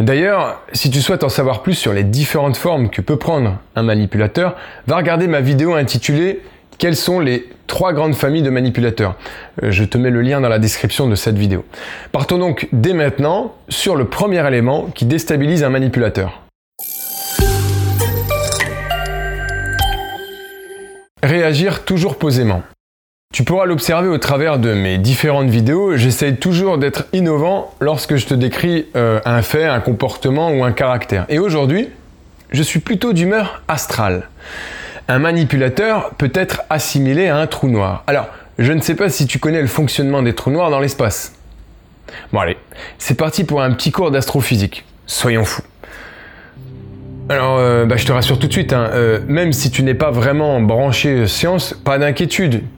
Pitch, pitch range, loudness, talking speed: 135 Hz, 115-155 Hz, -15 LUFS, 165 wpm